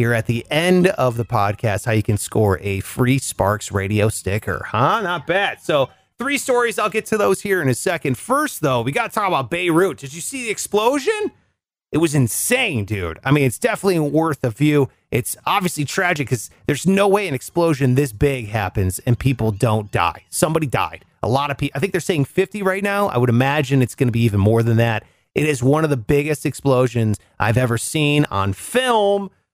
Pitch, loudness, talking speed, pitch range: 135 Hz, -19 LUFS, 215 wpm, 115-180 Hz